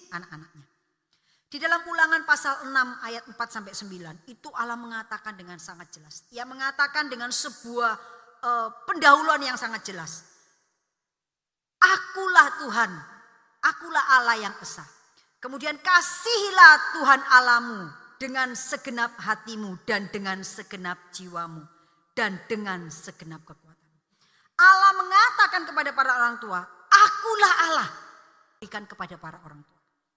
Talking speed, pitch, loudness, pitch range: 115 wpm, 230 Hz, -21 LUFS, 180-285 Hz